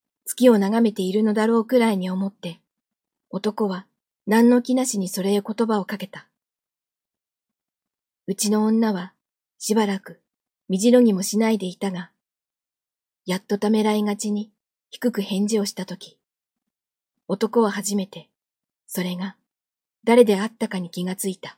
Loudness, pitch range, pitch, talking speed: -22 LUFS, 190-225 Hz, 210 Hz, 265 characters per minute